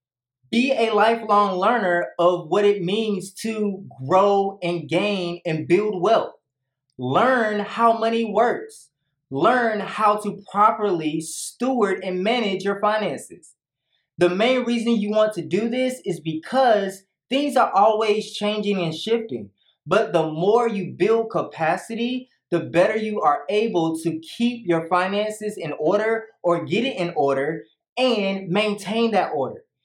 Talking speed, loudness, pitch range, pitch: 140 wpm, -21 LUFS, 170-225 Hz, 200 Hz